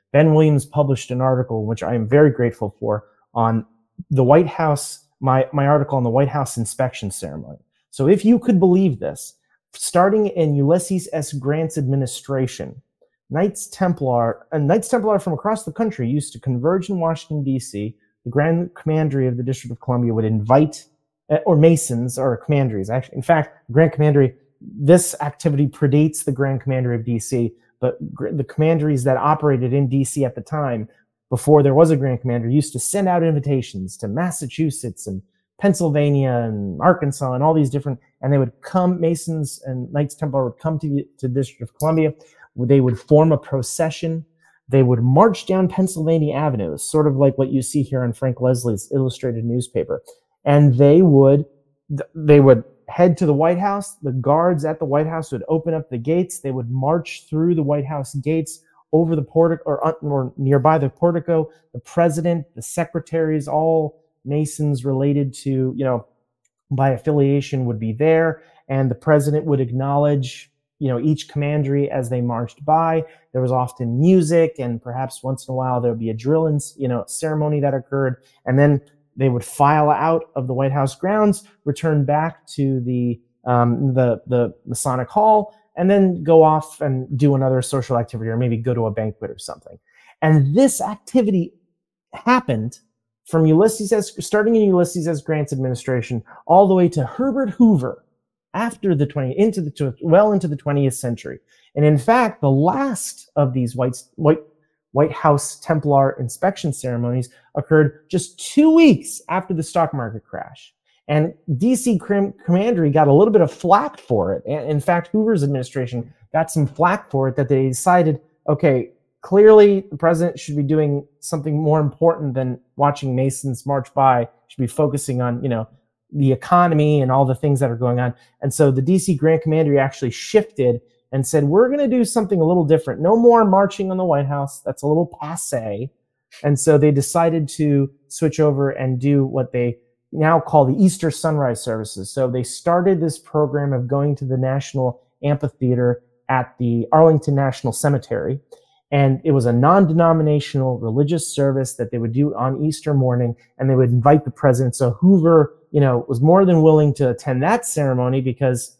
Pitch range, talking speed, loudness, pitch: 130-160 Hz, 180 wpm, -18 LUFS, 145 Hz